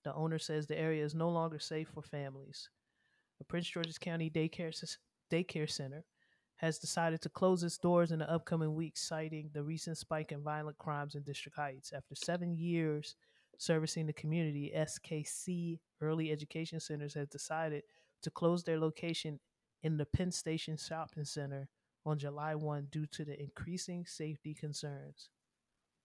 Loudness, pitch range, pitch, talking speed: -39 LUFS, 150-165 Hz, 155 Hz, 160 wpm